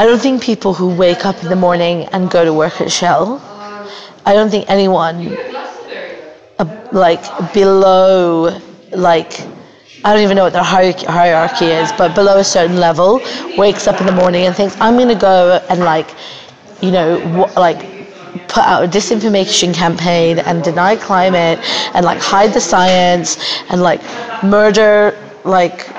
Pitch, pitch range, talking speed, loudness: 185 Hz, 175-205 Hz, 160 wpm, -11 LUFS